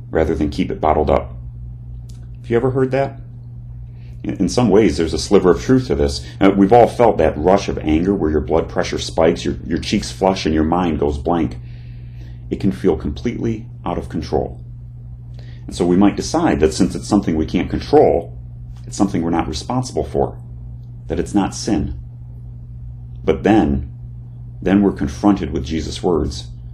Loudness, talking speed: -17 LUFS, 180 wpm